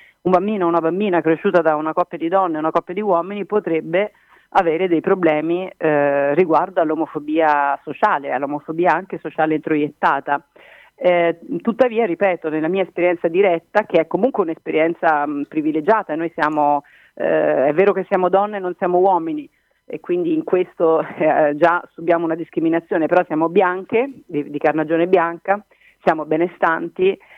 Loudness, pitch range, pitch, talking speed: -18 LUFS, 155-190 Hz, 170 Hz, 155 wpm